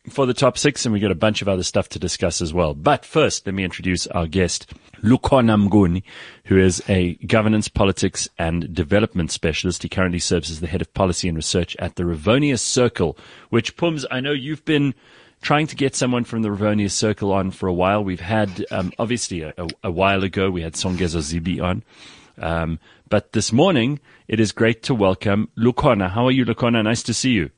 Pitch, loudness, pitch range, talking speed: 100 Hz, -20 LUFS, 90-115 Hz, 210 wpm